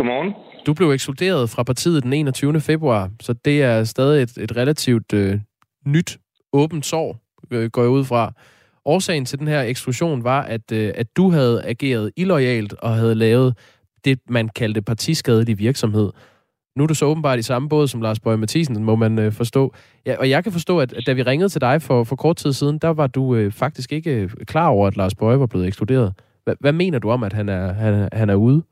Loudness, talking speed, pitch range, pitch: -19 LUFS, 215 wpm, 115-145 Hz, 125 Hz